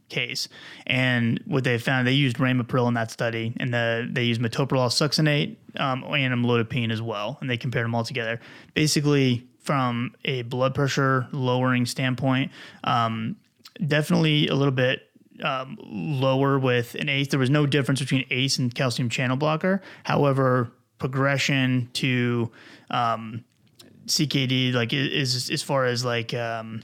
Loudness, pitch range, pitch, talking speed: -24 LUFS, 120-140 Hz, 130 Hz, 150 wpm